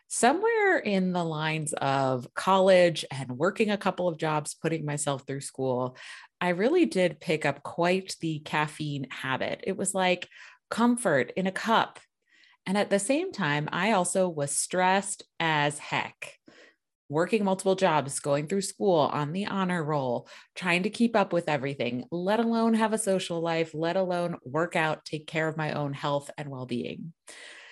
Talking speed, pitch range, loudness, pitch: 170 wpm, 150-195 Hz, -27 LUFS, 170 Hz